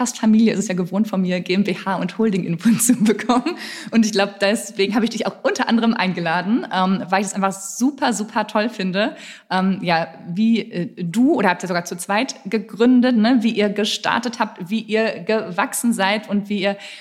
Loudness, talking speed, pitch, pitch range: -19 LUFS, 205 wpm, 205 Hz, 190-225 Hz